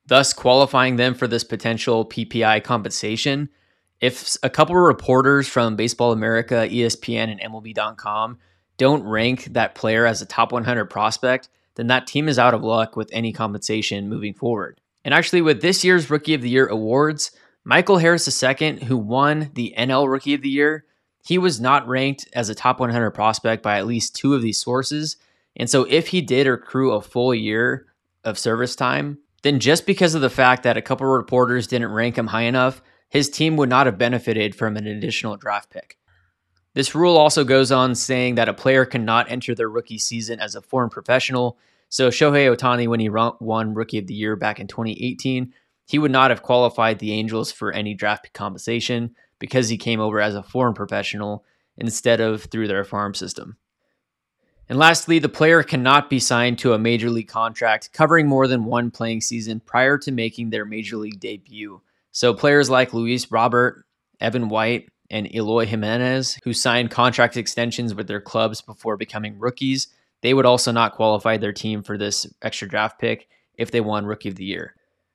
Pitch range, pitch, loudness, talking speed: 110-130 Hz, 120 Hz, -20 LUFS, 190 wpm